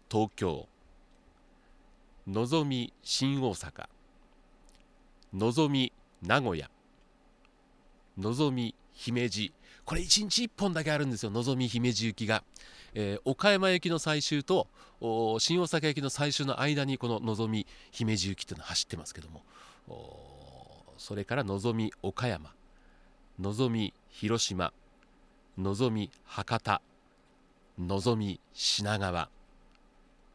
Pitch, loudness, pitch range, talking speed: 115 Hz, -31 LUFS, 105-145 Hz, 210 characters per minute